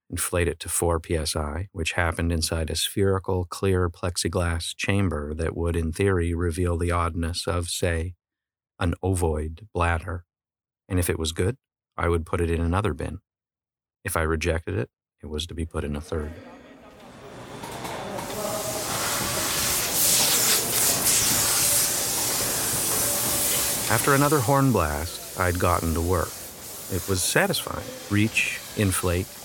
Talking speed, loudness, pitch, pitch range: 125 wpm, -24 LUFS, 85 Hz, 85-95 Hz